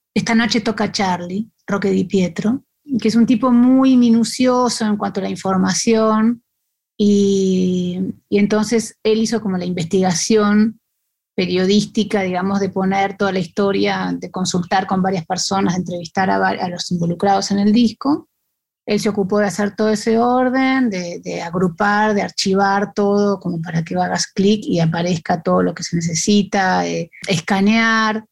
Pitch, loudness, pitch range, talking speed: 200 Hz, -17 LUFS, 185-220 Hz, 160 wpm